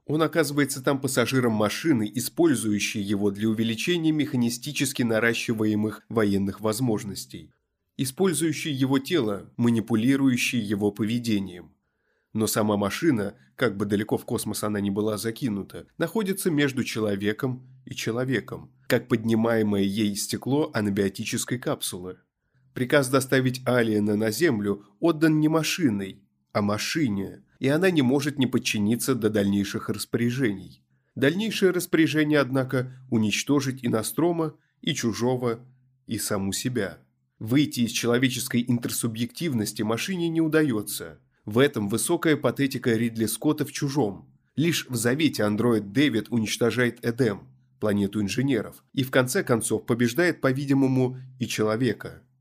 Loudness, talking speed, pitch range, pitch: -25 LUFS, 120 wpm, 105-135 Hz, 120 Hz